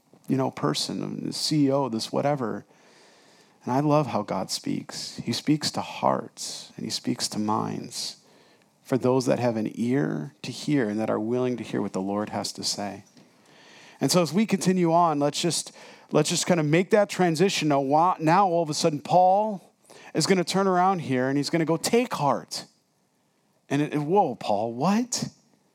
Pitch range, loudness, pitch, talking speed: 120-180 Hz, -25 LUFS, 150 Hz, 195 wpm